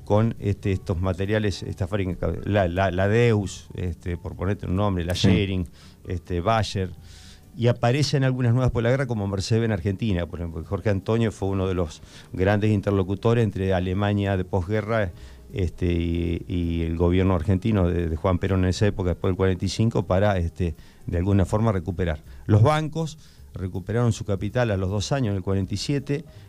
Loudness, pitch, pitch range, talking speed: -24 LUFS, 100 Hz, 90-110 Hz, 175 wpm